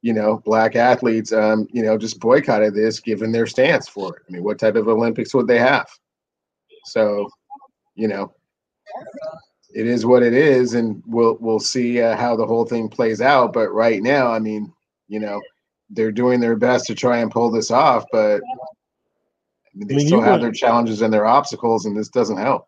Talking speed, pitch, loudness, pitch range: 195 wpm, 115 Hz, -18 LUFS, 110-125 Hz